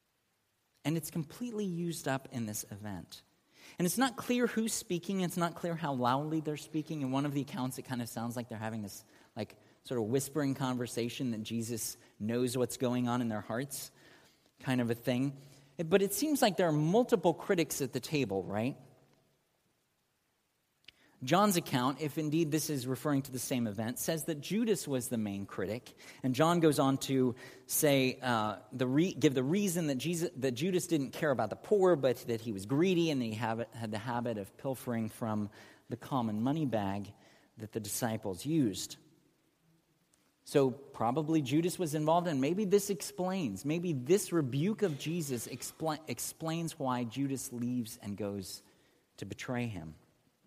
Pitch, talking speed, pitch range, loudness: 135 Hz, 175 wpm, 120-160 Hz, -34 LUFS